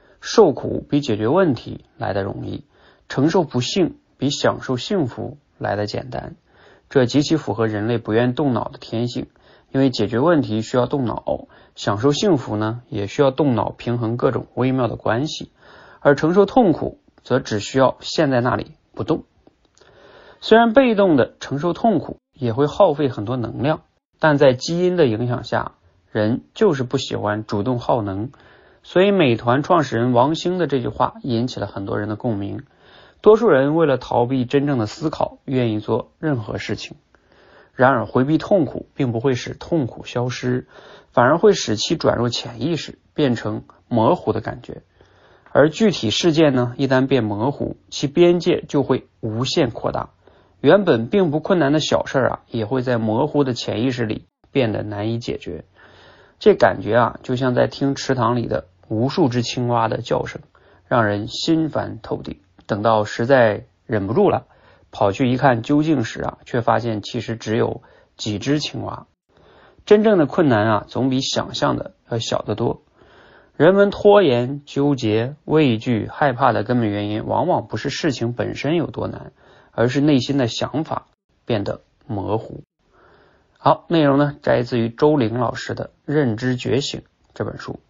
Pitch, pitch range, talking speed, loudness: 125 Hz, 115-150 Hz, 245 characters per minute, -19 LUFS